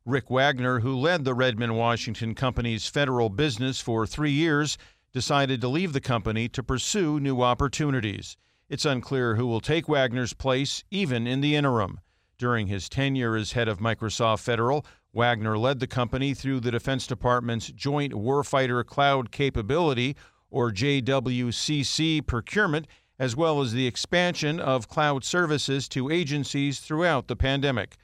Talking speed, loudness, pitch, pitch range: 150 wpm, -26 LUFS, 130 Hz, 120-145 Hz